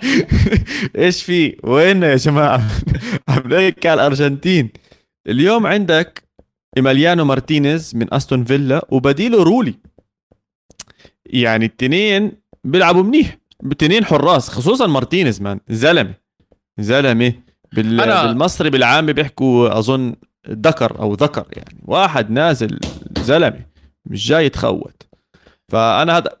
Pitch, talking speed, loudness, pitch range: 140 Hz, 100 wpm, -15 LUFS, 115-170 Hz